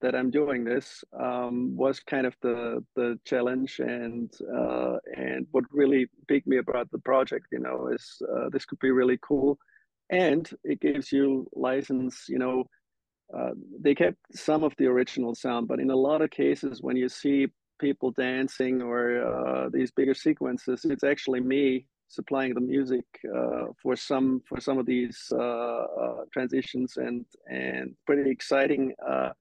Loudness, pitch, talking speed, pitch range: -28 LUFS, 125 Hz, 165 wpm, 120-135 Hz